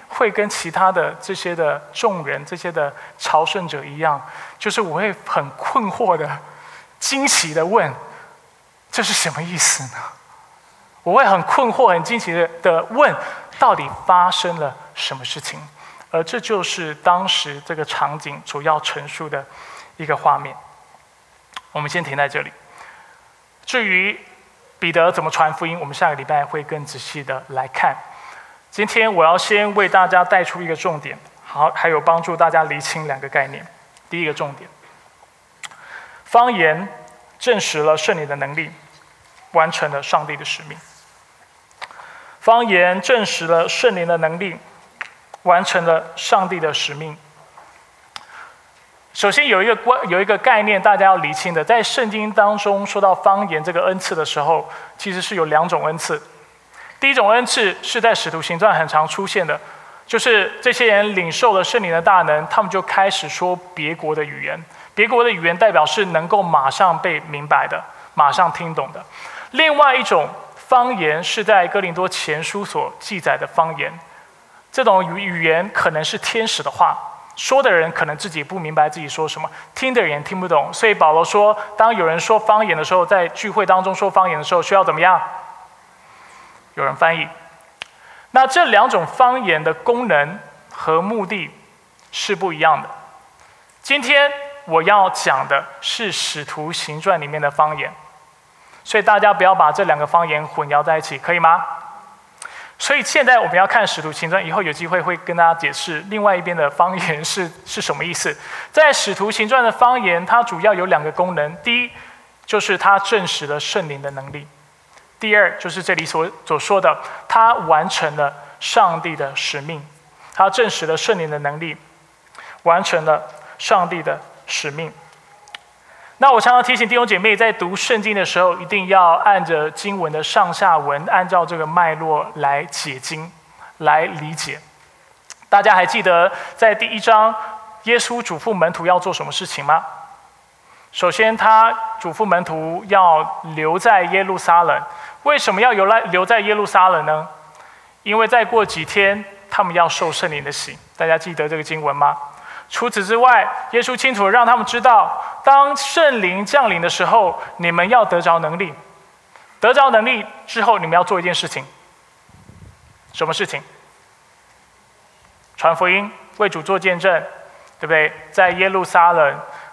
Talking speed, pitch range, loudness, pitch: 245 characters per minute, 160-215 Hz, -16 LUFS, 180 Hz